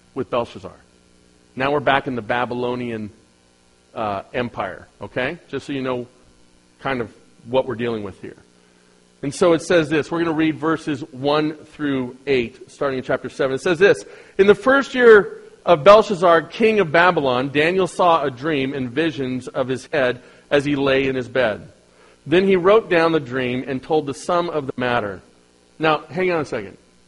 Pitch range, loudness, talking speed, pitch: 120-165 Hz, -19 LUFS, 185 wpm, 135 Hz